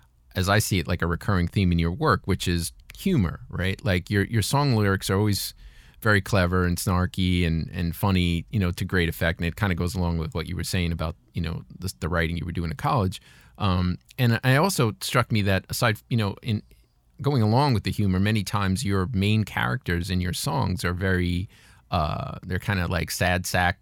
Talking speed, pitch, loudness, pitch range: 225 wpm, 95 Hz, -25 LUFS, 85-105 Hz